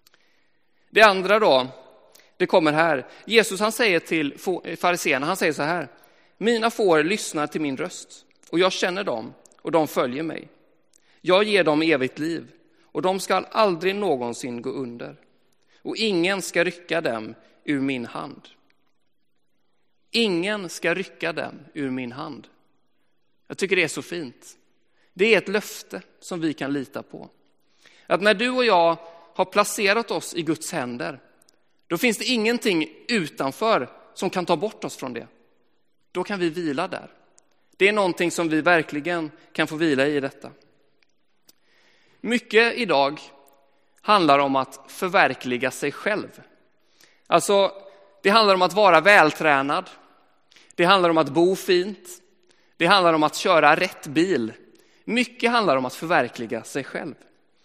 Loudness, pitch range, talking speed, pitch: -22 LUFS, 150-205 Hz, 150 wpm, 175 Hz